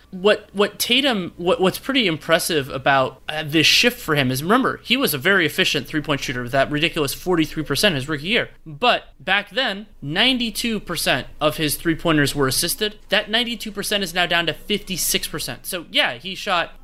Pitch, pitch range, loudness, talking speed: 175 Hz, 155-210 Hz, -19 LUFS, 175 wpm